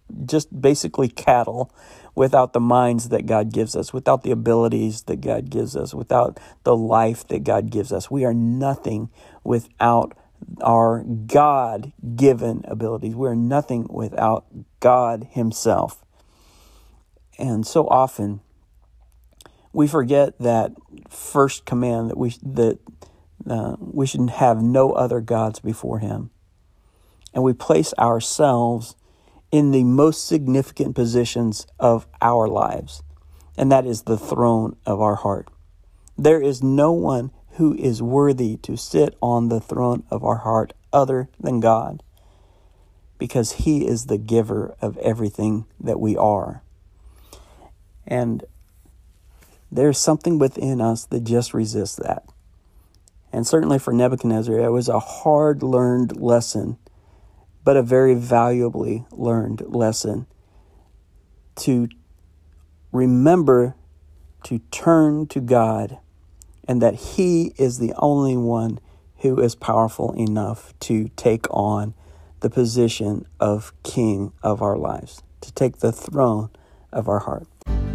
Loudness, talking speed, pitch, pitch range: -20 LUFS, 125 wpm, 115 Hz, 95-125 Hz